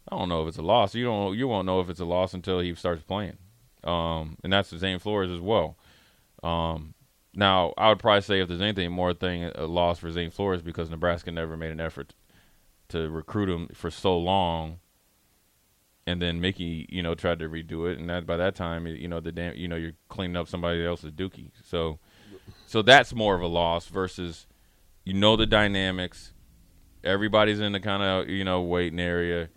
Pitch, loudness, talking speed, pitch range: 90 Hz, -26 LUFS, 205 wpm, 85-95 Hz